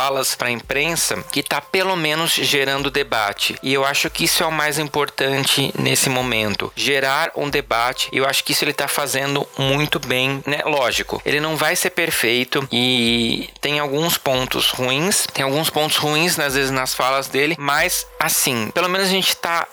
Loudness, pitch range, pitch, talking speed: -18 LUFS, 135-155 Hz, 140 Hz, 185 wpm